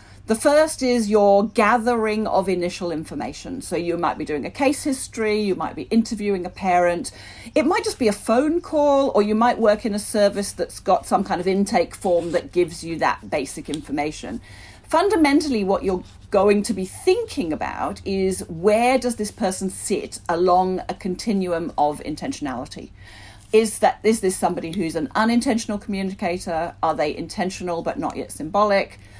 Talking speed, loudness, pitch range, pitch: 175 wpm, -21 LUFS, 175-230 Hz, 200 Hz